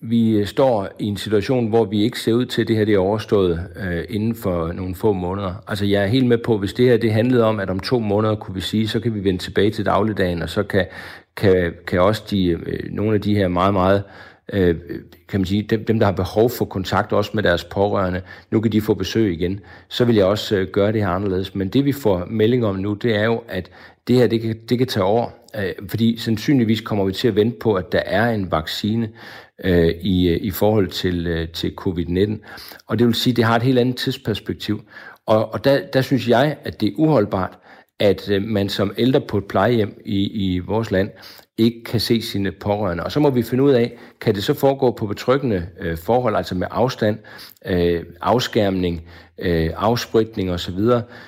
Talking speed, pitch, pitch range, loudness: 220 wpm, 105 Hz, 95-115 Hz, -20 LUFS